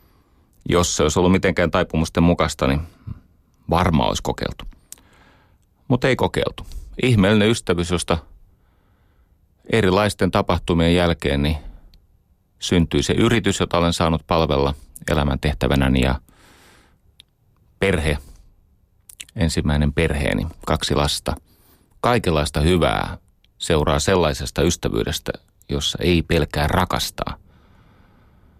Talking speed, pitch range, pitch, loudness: 95 wpm, 75-90 Hz, 85 Hz, -20 LUFS